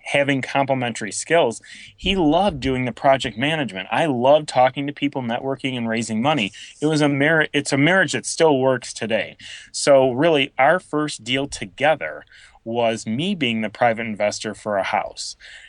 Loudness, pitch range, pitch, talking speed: -20 LUFS, 115-145 Hz, 135 Hz, 170 wpm